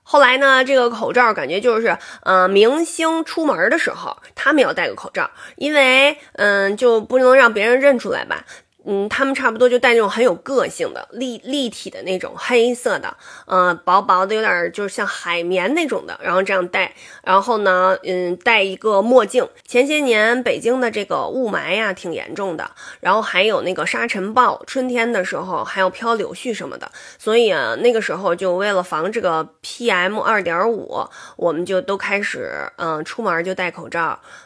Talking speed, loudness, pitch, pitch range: 285 characters per minute, -17 LUFS, 230 Hz, 190-270 Hz